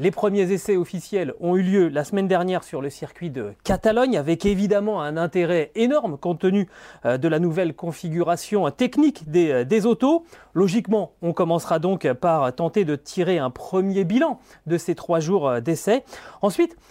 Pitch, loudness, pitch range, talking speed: 185 Hz, -22 LUFS, 165-205 Hz, 165 wpm